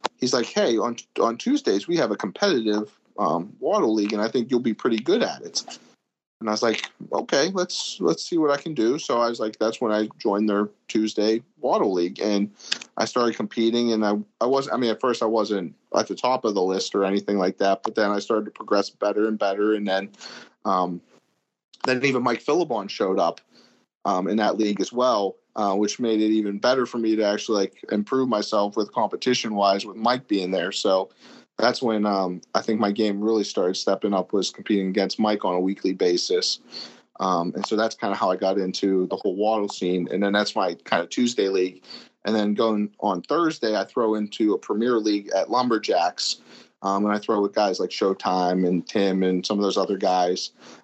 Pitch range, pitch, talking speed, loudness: 100-115 Hz, 105 Hz, 220 wpm, -23 LUFS